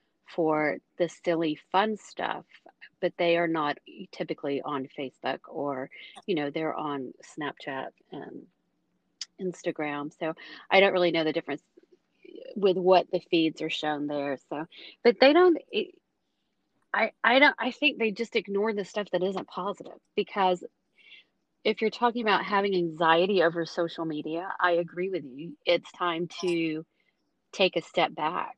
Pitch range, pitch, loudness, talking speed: 160-205 Hz, 175 Hz, -27 LUFS, 150 wpm